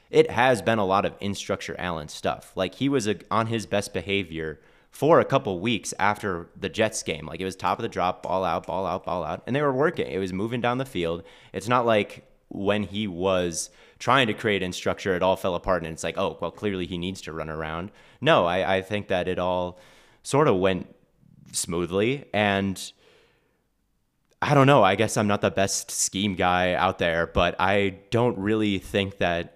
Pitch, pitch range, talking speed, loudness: 95 Hz, 90-105 Hz, 210 wpm, -25 LUFS